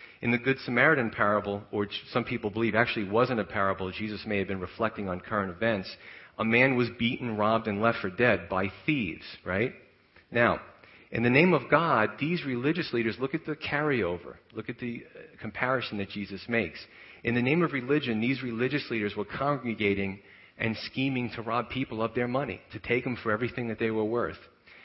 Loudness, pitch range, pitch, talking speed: -28 LUFS, 105-125 Hz, 115 Hz, 195 wpm